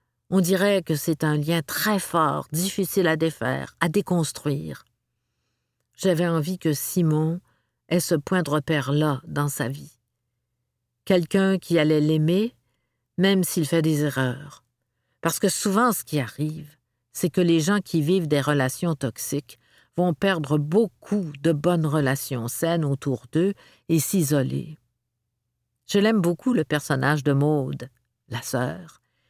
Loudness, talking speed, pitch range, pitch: -23 LUFS, 140 wpm, 135-180 Hz, 155 Hz